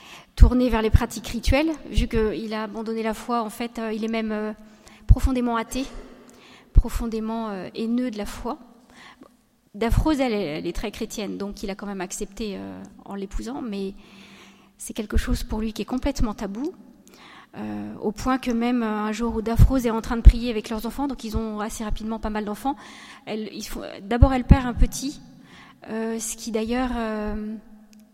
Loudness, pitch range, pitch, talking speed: -25 LUFS, 215-240 Hz, 225 Hz, 190 wpm